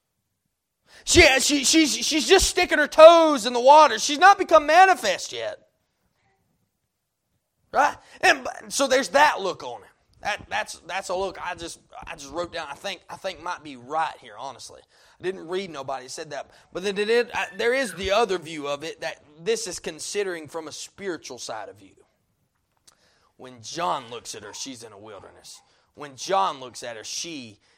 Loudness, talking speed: -20 LUFS, 190 wpm